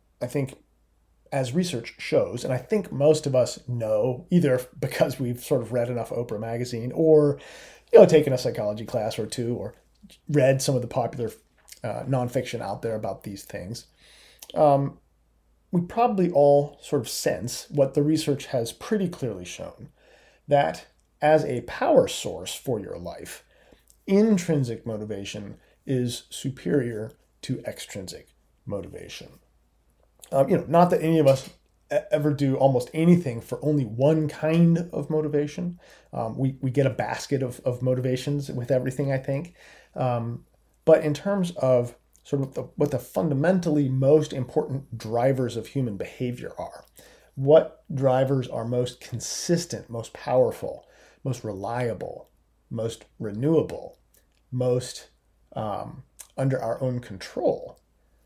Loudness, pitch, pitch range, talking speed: -25 LUFS, 135 Hz, 120-155 Hz, 140 wpm